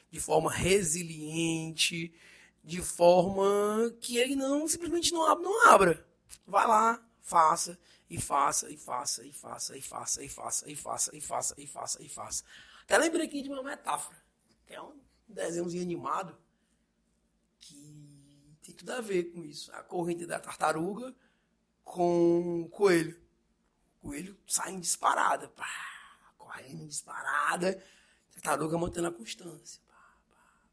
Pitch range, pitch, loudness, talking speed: 165-215 Hz, 180 Hz, -29 LUFS, 135 wpm